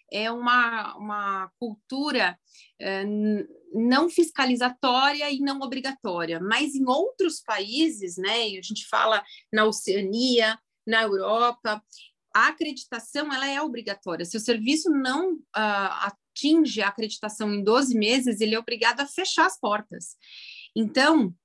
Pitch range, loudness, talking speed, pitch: 210-275 Hz, -25 LUFS, 130 wpm, 230 Hz